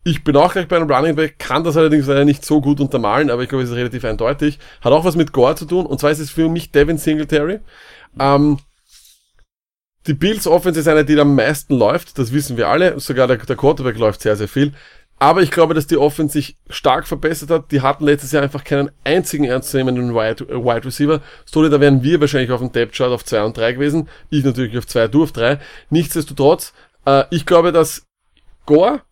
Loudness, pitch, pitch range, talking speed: -16 LUFS, 145 Hz, 135-155 Hz, 225 wpm